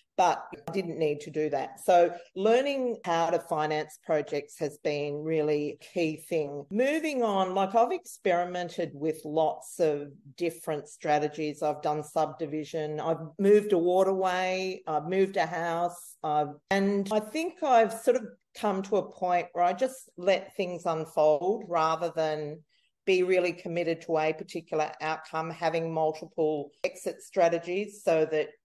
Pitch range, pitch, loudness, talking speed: 155-195 Hz, 170 Hz, -29 LUFS, 150 wpm